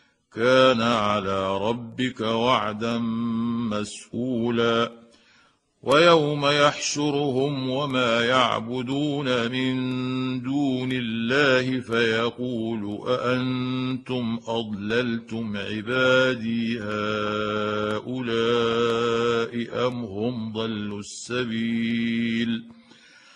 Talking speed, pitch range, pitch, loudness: 55 wpm, 115-130 Hz, 120 Hz, -24 LUFS